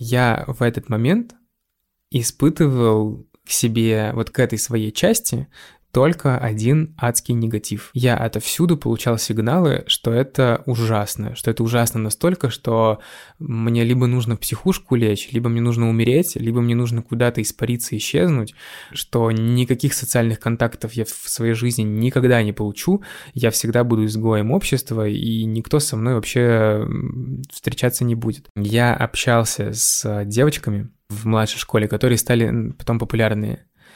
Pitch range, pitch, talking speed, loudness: 110-125 Hz, 115 Hz, 140 wpm, -19 LUFS